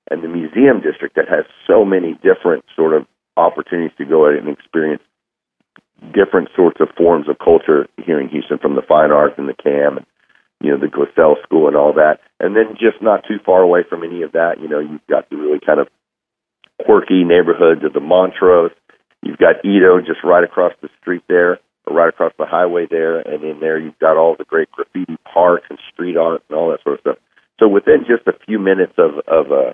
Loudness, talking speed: -14 LUFS, 220 wpm